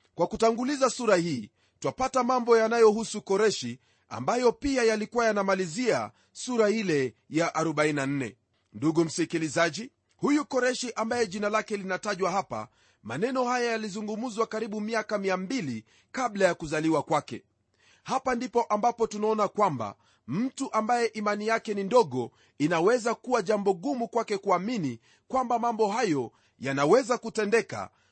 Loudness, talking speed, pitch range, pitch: -27 LUFS, 120 wpm, 165-235 Hz, 215 Hz